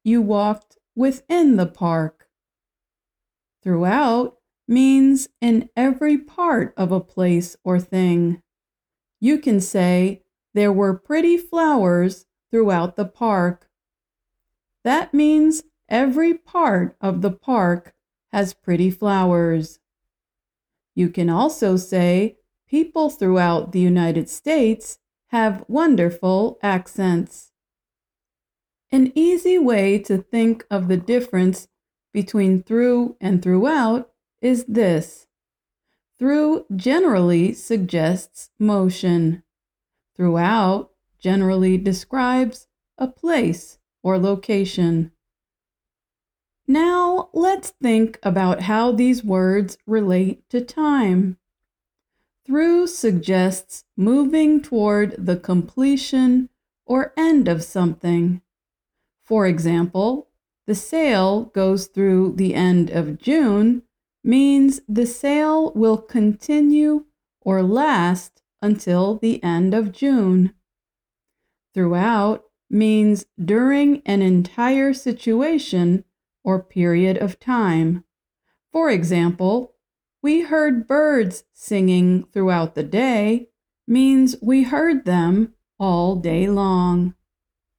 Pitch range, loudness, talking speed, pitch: 185-255 Hz, -19 LUFS, 95 wpm, 205 Hz